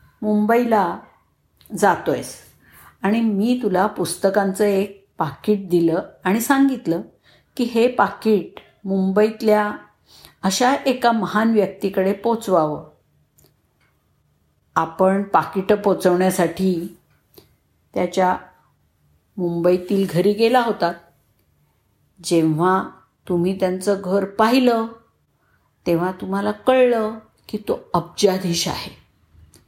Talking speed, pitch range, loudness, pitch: 85 wpm, 175-215 Hz, -20 LUFS, 195 Hz